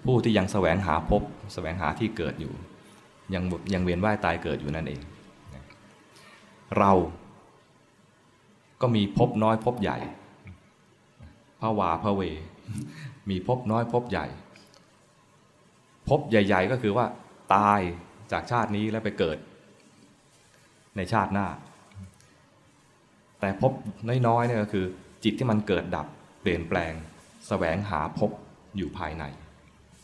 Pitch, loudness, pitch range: 100 Hz, -27 LUFS, 90-110 Hz